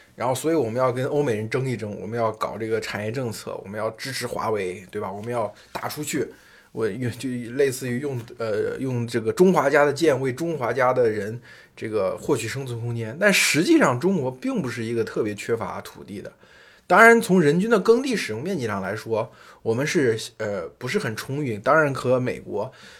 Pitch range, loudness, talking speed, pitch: 115-160 Hz, -23 LUFS, 305 characters per minute, 130 Hz